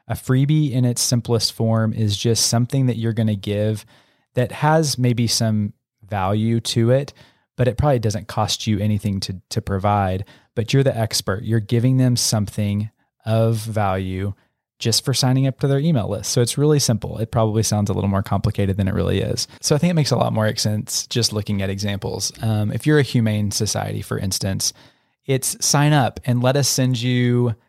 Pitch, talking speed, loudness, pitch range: 115 Hz, 200 wpm, -20 LUFS, 105-125 Hz